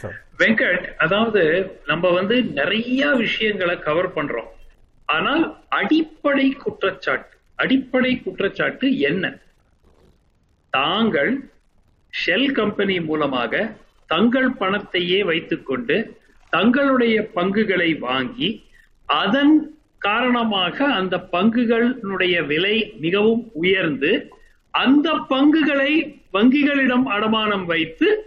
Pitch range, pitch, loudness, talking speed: 190-270 Hz, 230 Hz, -19 LUFS, 80 wpm